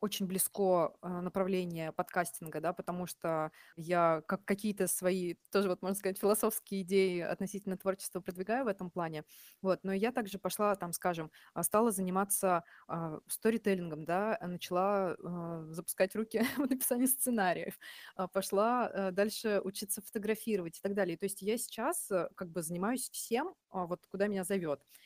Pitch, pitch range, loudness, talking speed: 190 Hz, 180-210 Hz, -35 LUFS, 140 wpm